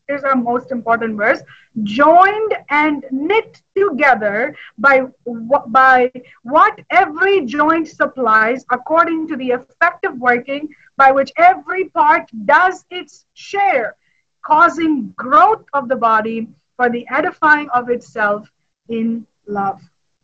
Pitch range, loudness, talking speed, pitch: 240-335 Hz, -15 LUFS, 120 wpm, 275 Hz